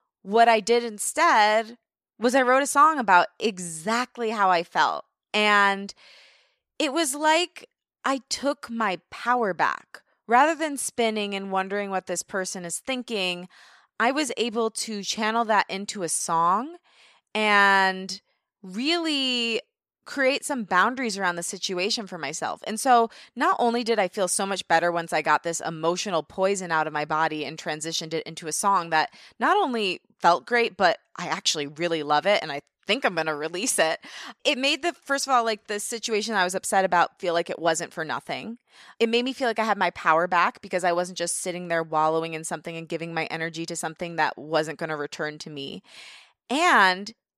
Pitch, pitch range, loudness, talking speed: 195 Hz, 170-235 Hz, -24 LUFS, 190 wpm